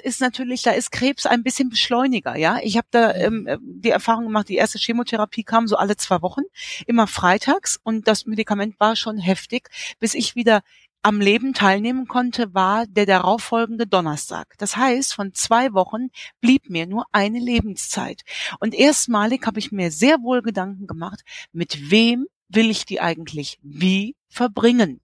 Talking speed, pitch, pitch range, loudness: 170 wpm, 225 Hz, 200-245 Hz, -20 LUFS